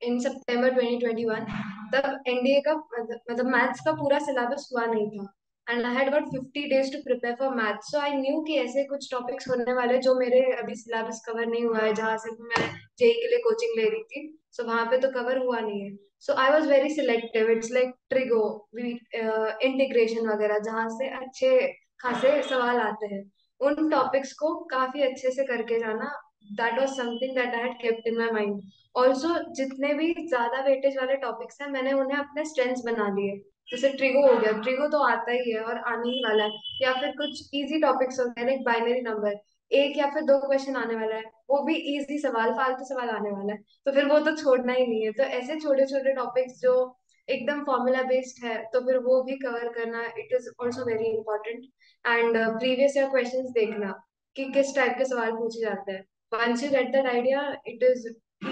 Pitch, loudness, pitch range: 255 Hz, -26 LUFS, 230-275 Hz